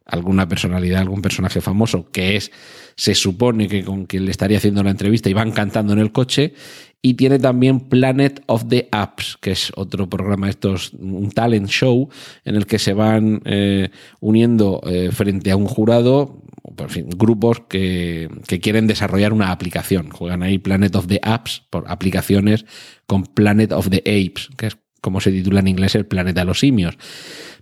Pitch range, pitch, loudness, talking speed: 95-110 Hz, 100 Hz, -17 LUFS, 185 wpm